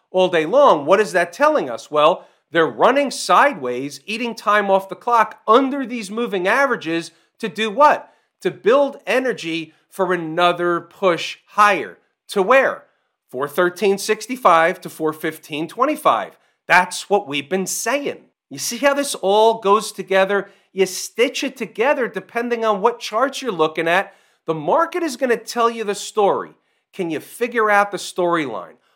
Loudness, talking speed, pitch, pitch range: -18 LUFS, 155 wpm, 200 Hz, 175-235 Hz